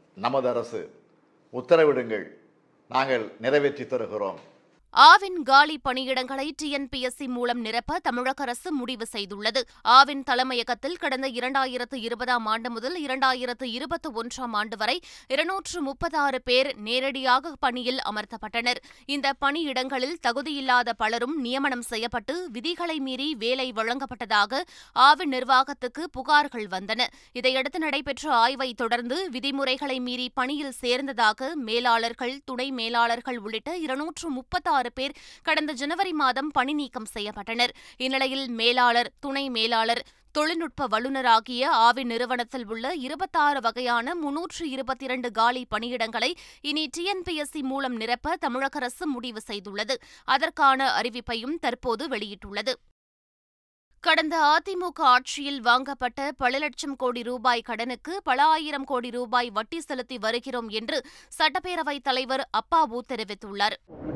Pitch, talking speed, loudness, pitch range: 260 Hz, 110 wpm, -25 LUFS, 245-295 Hz